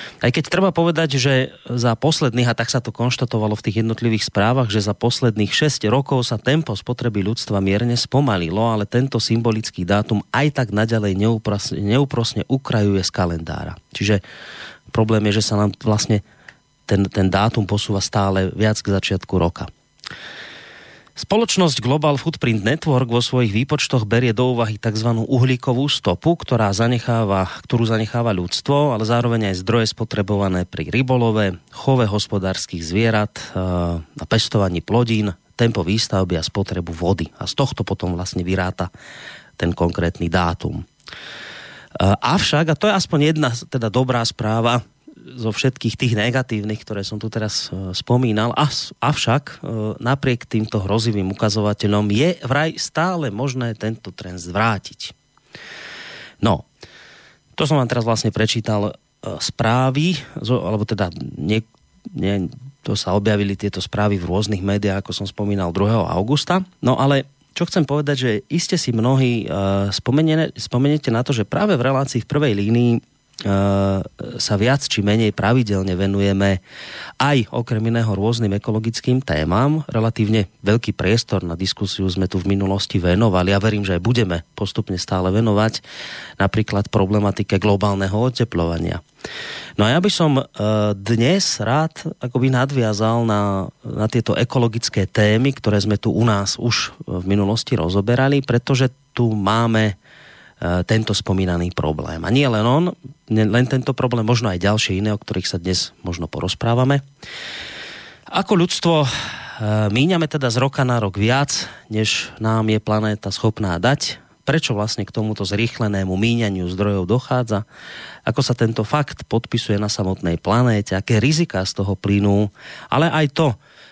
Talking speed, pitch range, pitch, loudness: 140 wpm, 100-125 Hz, 110 Hz, -19 LUFS